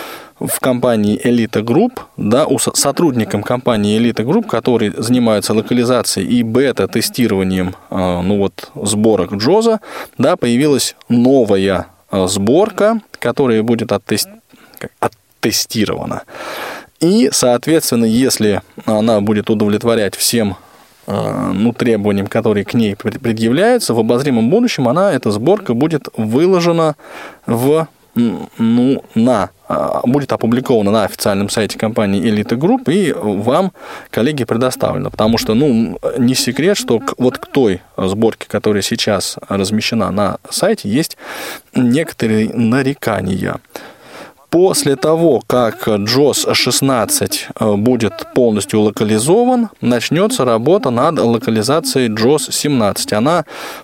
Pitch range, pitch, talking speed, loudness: 105-135 Hz, 115 Hz, 105 wpm, -14 LUFS